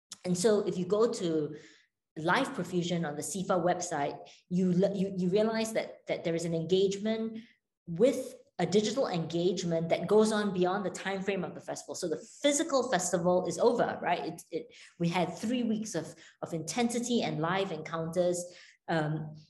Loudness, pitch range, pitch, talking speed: -31 LUFS, 170-220 Hz, 185 Hz, 170 wpm